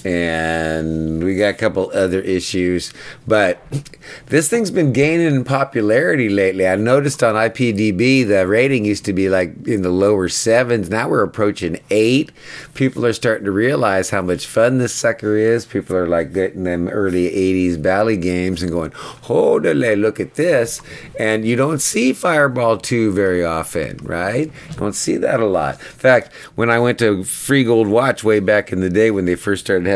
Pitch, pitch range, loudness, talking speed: 105 Hz, 95-125 Hz, -17 LUFS, 185 wpm